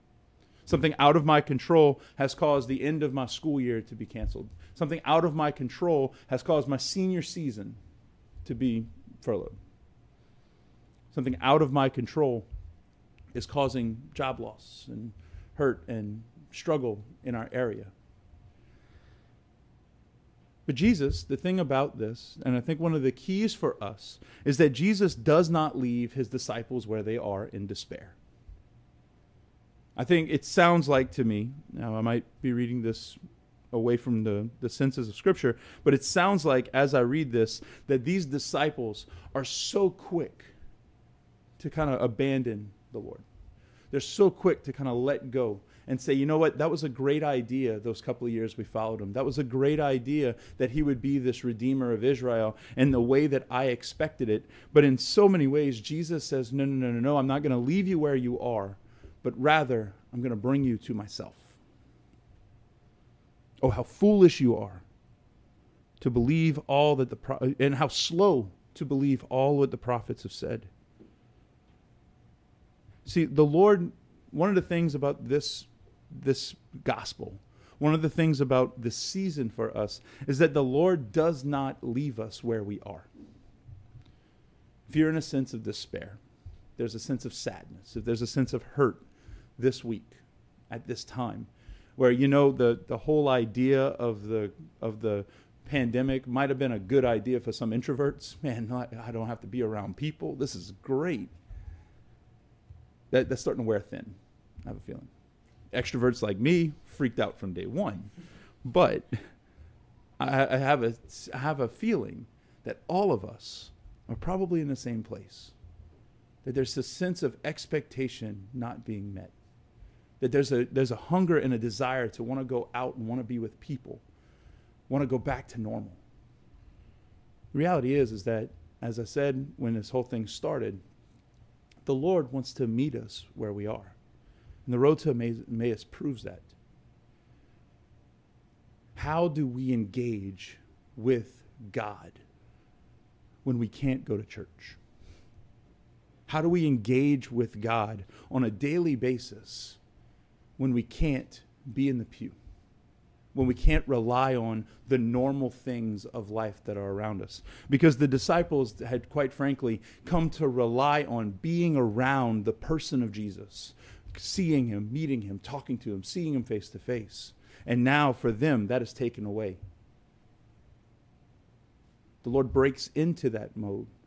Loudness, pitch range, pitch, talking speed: -29 LUFS, 110-140 Hz, 125 Hz, 165 wpm